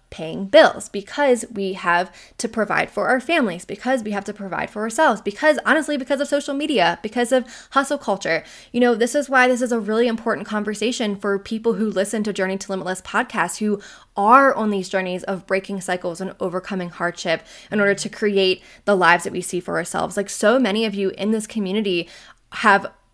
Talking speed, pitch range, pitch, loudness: 200 wpm, 190-240 Hz, 210 Hz, -20 LUFS